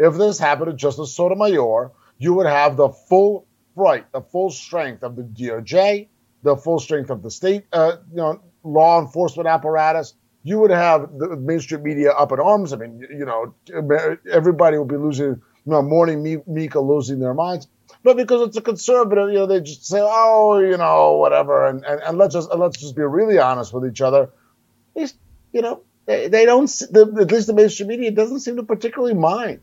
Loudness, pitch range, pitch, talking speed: -18 LUFS, 145-205 Hz, 165 Hz, 205 wpm